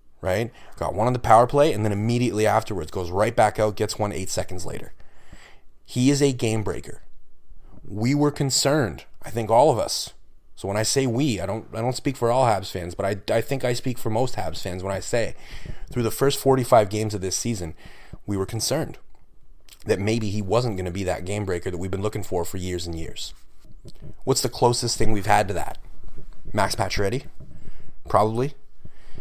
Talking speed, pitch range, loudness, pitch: 205 wpm, 95-125 Hz, -23 LUFS, 110 Hz